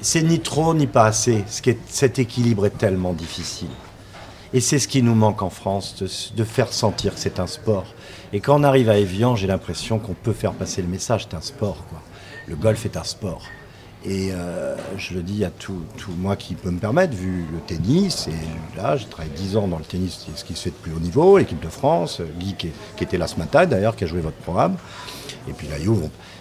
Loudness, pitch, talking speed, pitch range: -22 LUFS, 100 Hz, 235 wpm, 90-115 Hz